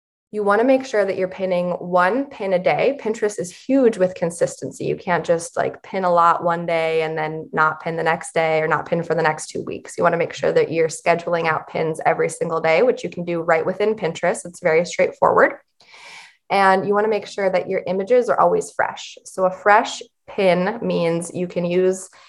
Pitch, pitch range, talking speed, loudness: 180 Hz, 170-210 Hz, 225 wpm, -20 LUFS